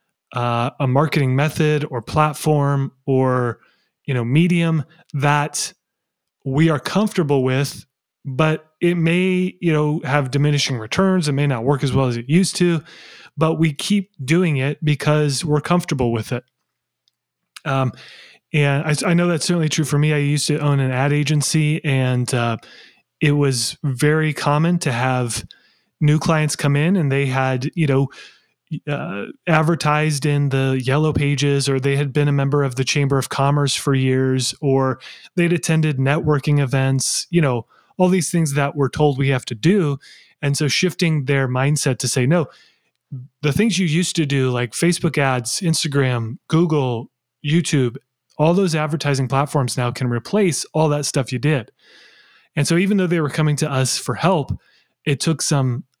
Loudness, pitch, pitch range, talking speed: -19 LUFS, 145 Hz, 135-160 Hz, 170 wpm